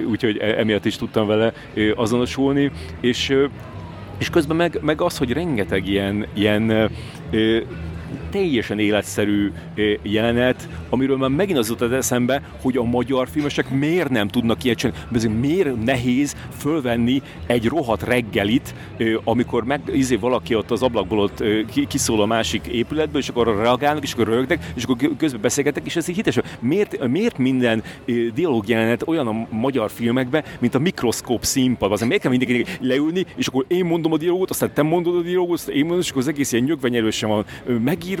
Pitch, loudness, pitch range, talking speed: 125 Hz, -20 LUFS, 110-140 Hz, 165 wpm